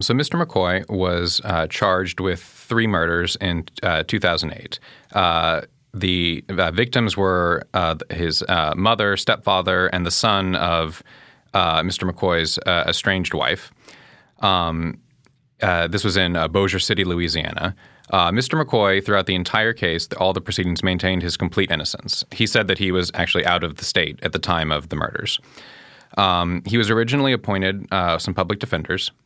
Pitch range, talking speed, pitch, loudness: 85-100 Hz, 165 wpm, 95 Hz, -20 LUFS